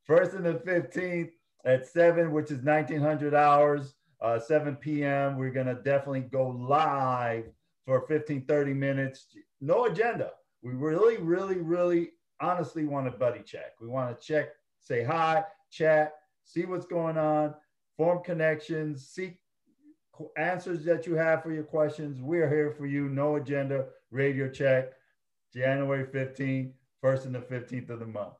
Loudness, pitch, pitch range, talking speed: -29 LUFS, 150 Hz, 135-165 Hz, 150 wpm